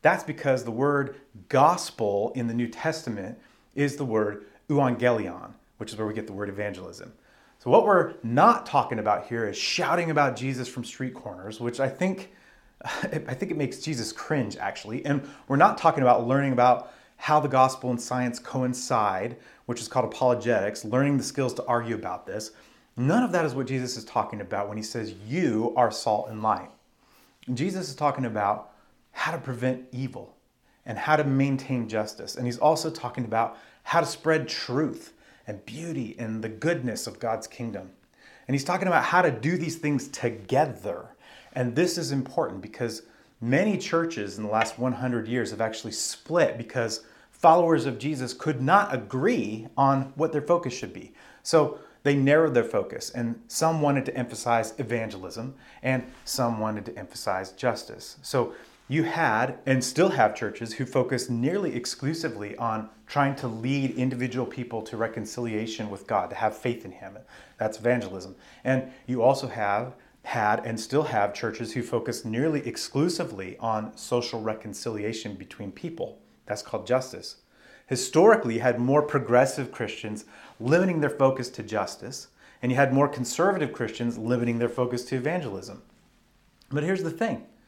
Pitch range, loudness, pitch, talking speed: 115-140 Hz, -26 LUFS, 125 Hz, 170 wpm